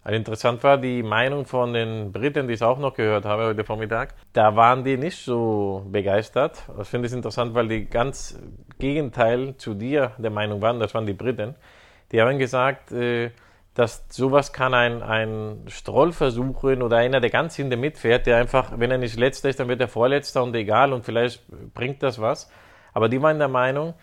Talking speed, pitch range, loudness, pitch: 195 wpm, 110-130 Hz, -22 LUFS, 120 Hz